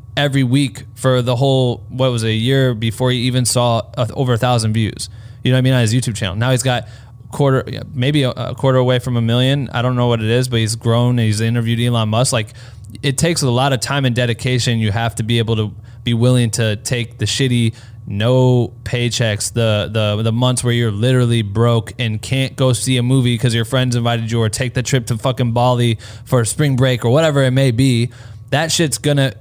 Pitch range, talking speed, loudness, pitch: 115-130 Hz, 230 wpm, -16 LUFS, 120 Hz